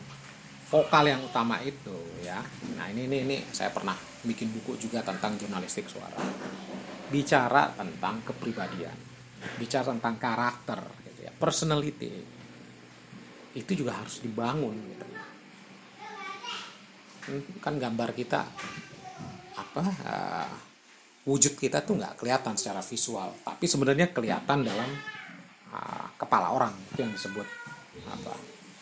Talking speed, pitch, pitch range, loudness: 110 wpm, 135 Hz, 115-150 Hz, -30 LUFS